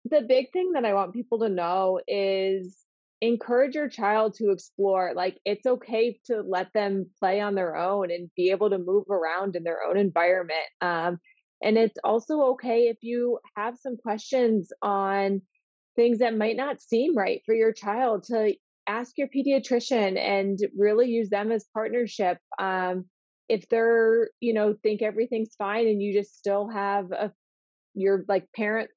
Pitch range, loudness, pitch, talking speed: 195-235 Hz, -26 LUFS, 210 Hz, 170 wpm